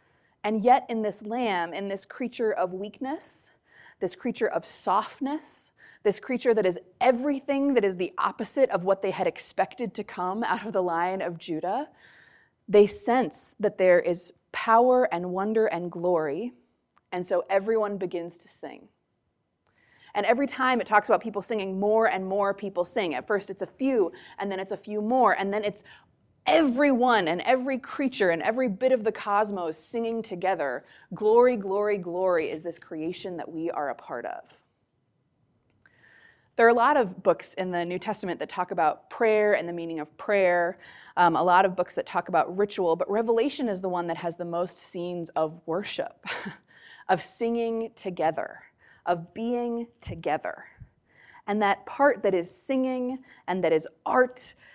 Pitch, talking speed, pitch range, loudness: 205 Hz, 175 wpm, 180-235 Hz, -26 LUFS